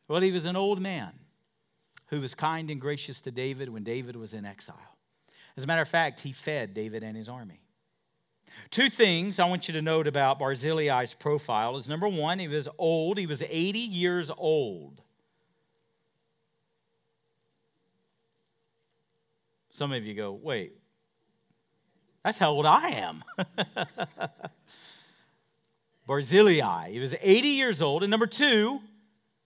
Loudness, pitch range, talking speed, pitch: -27 LUFS, 135-185 Hz, 140 wpm, 155 Hz